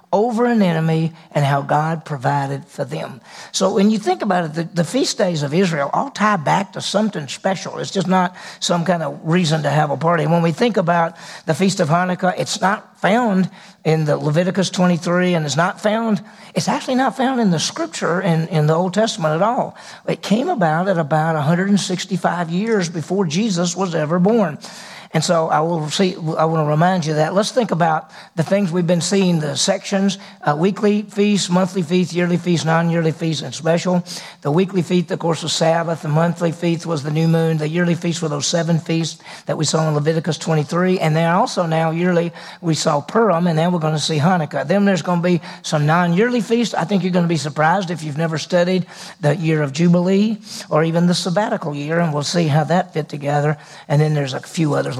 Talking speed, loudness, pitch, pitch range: 220 wpm, -18 LUFS, 175 Hz, 160-190 Hz